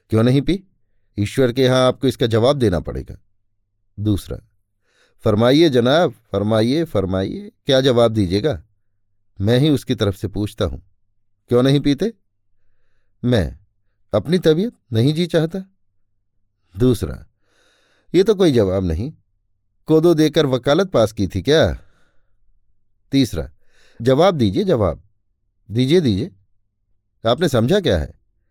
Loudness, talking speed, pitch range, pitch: -18 LUFS, 120 wpm, 100-130 Hz, 105 Hz